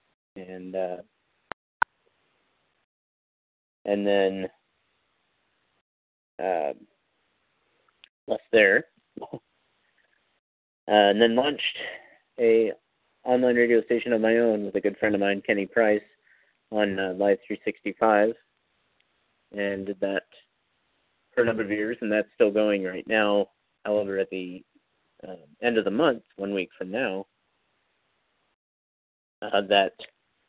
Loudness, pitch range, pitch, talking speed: -25 LUFS, 95-110 Hz, 100 Hz, 115 wpm